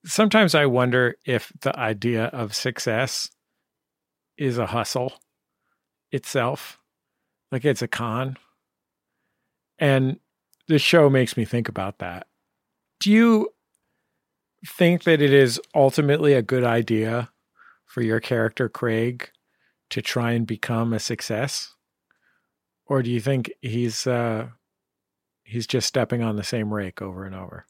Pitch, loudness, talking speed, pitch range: 120 Hz, -22 LUFS, 130 wpm, 115-135 Hz